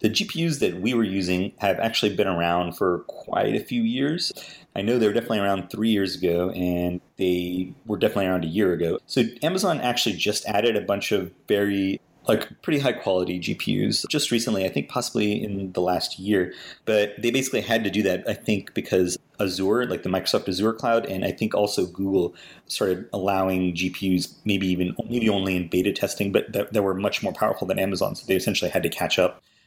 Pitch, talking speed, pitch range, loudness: 95 Hz, 205 wpm, 90-110 Hz, -24 LUFS